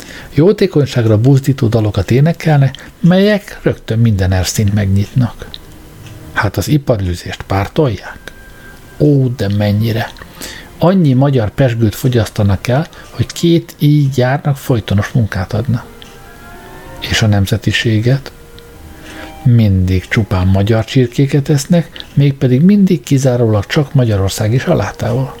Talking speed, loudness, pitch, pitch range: 100 wpm, -13 LUFS, 120 Hz, 100-140 Hz